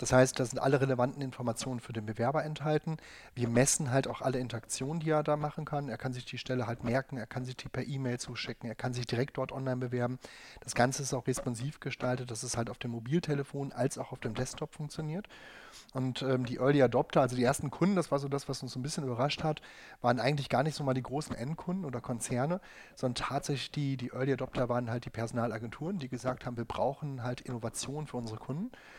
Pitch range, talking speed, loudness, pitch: 125-140 Hz, 230 wpm, -34 LUFS, 130 Hz